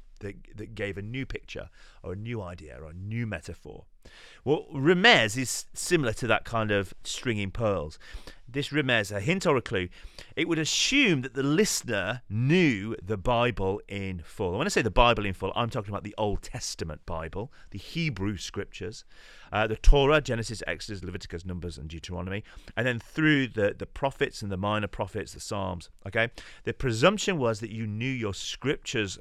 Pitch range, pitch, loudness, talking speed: 95-125 Hz, 110 Hz, -28 LUFS, 185 wpm